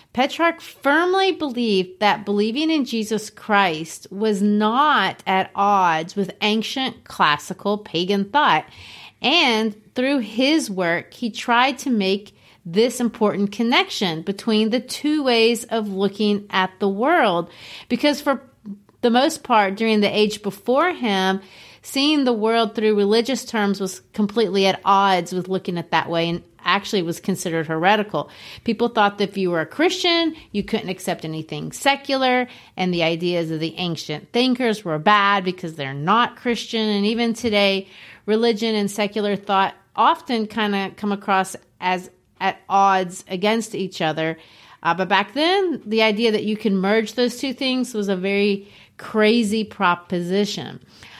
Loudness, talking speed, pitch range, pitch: -20 LUFS, 150 wpm, 190-235 Hz, 210 Hz